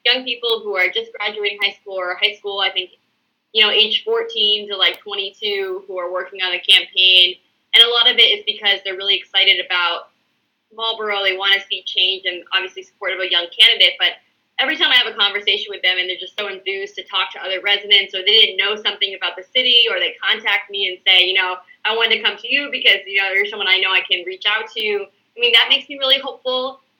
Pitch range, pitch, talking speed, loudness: 190-225 Hz, 200 Hz, 245 wpm, -15 LUFS